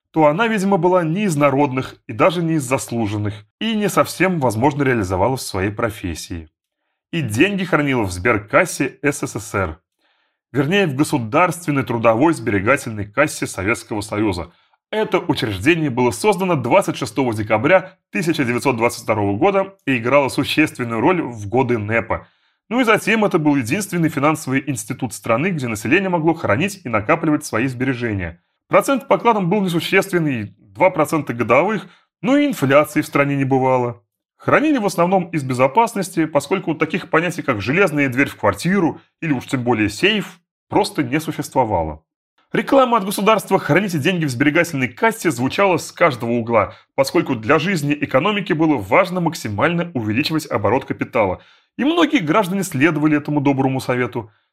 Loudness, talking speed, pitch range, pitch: -18 LUFS, 145 wpm, 120-180 Hz, 145 Hz